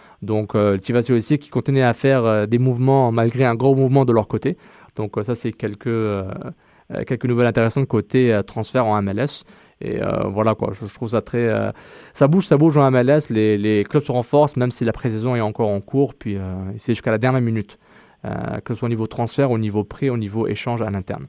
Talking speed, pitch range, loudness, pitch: 235 wpm, 110-130 Hz, -19 LUFS, 120 Hz